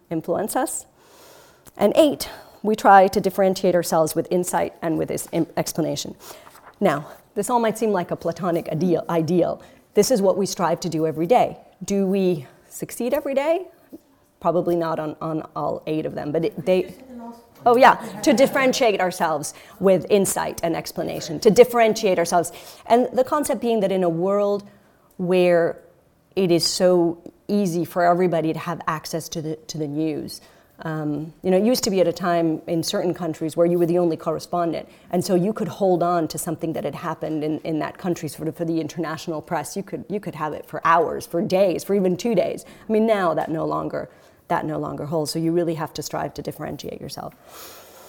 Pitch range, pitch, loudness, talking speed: 160-205 Hz, 175 Hz, -22 LUFS, 195 wpm